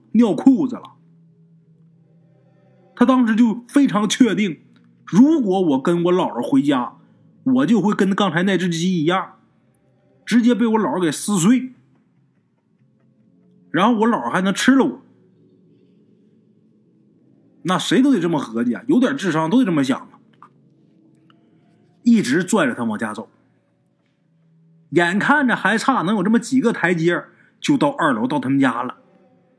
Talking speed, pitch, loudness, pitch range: 205 characters per minute, 215 Hz, -18 LUFS, 170-255 Hz